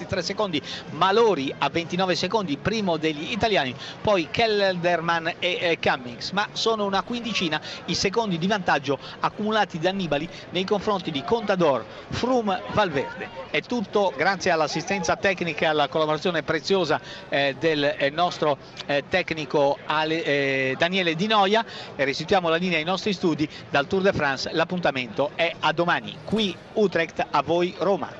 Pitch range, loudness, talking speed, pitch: 155-195 Hz, -24 LUFS, 150 wpm, 175 Hz